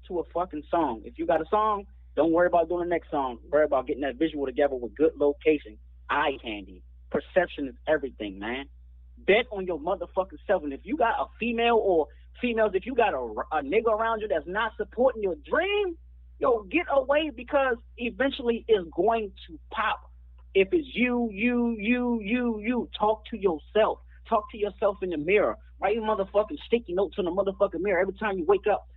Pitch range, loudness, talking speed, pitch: 150-230 Hz, -27 LUFS, 200 wpm, 200 Hz